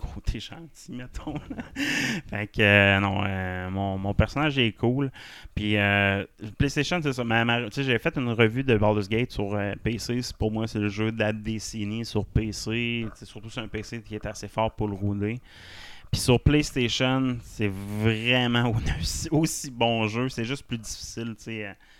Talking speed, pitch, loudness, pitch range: 190 wpm, 110 Hz, -26 LUFS, 100-120 Hz